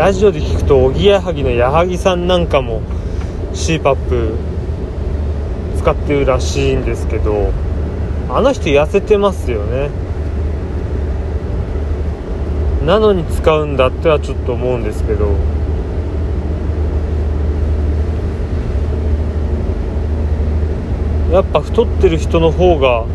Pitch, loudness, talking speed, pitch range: 80 Hz, -16 LUFS, 205 characters per minute, 75-90 Hz